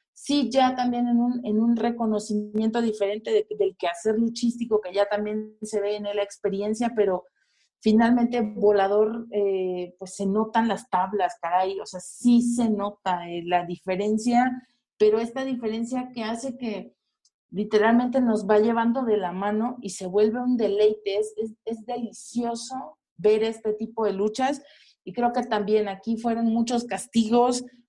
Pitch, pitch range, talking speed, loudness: 220 Hz, 205-240 Hz, 160 wpm, -25 LUFS